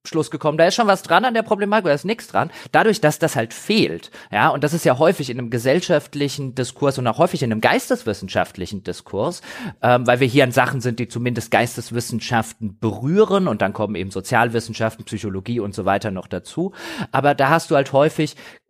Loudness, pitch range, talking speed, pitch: -19 LUFS, 115-165 Hz, 205 wpm, 135 Hz